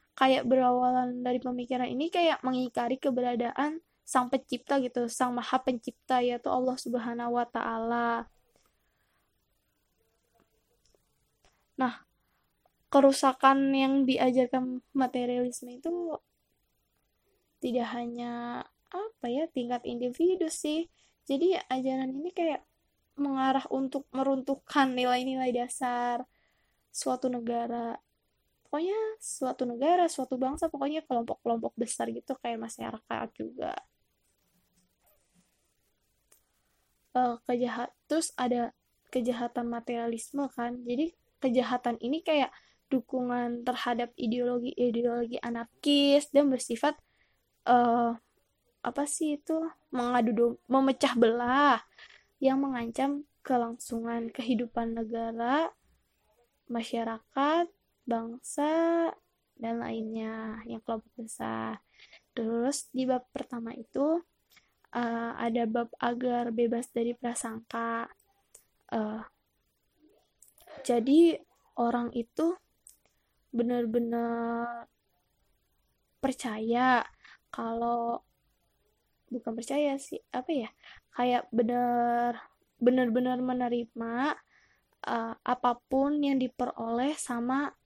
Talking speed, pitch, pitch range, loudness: 85 wpm, 250 Hz, 235-275 Hz, -30 LUFS